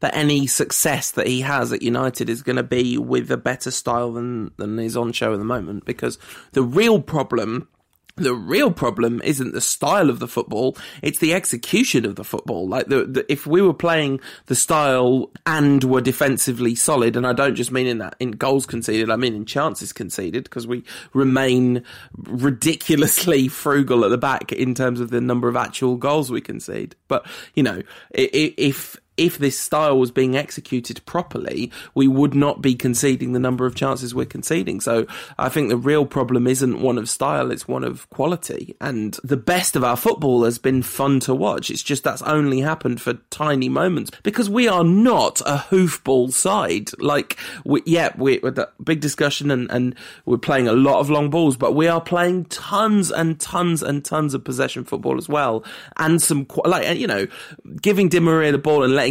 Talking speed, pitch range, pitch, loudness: 195 wpm, 125-150 Hz, 130 Hz, -20 LUFS